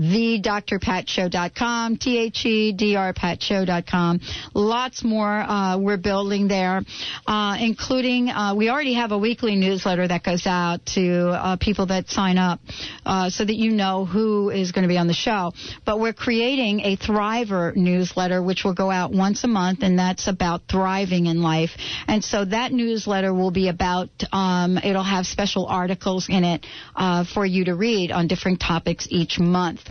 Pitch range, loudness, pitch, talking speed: 180-215 Hz, -22 LUFS, 195 Hz, 165 wpm